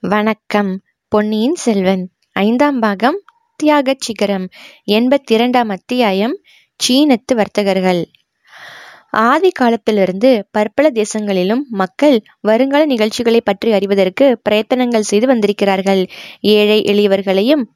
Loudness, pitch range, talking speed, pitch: -14 LUFS, 200-255 Hz, 90 wpm, 220 Hz